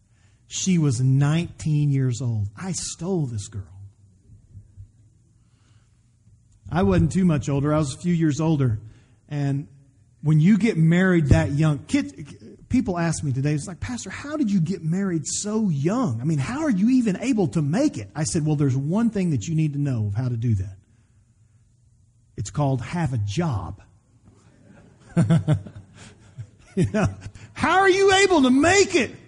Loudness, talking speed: -22 LUFS, 170 wpm